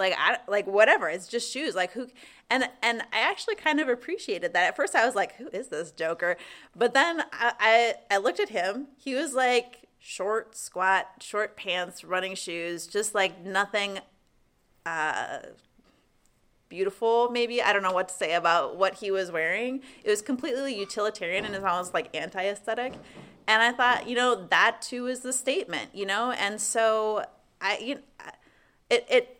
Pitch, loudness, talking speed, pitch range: 225 Hz, -27 LUFS, 180 wpm, 195-255 Hz